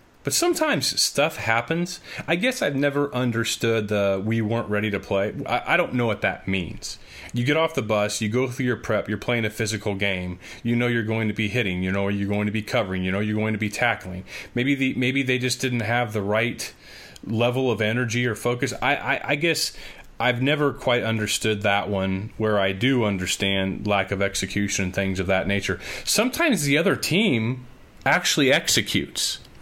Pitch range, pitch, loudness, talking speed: 100-125 Hz, 110 Hz, -23 LUFS, 205 wpm